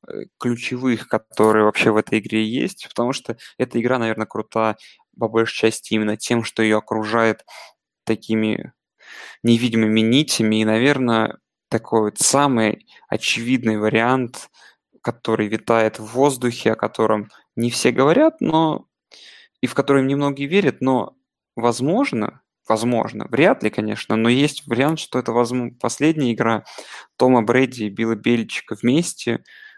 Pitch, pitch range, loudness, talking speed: 115 Hz, 110-130 Hz, -19 LUFS, 135 wpm